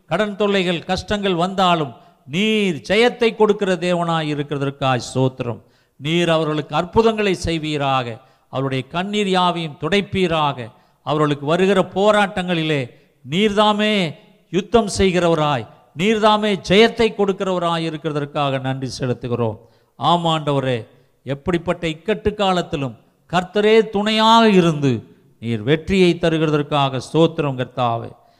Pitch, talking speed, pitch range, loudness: 165 Hz, 90 wpm, 140-195 Hz, -18 LUFS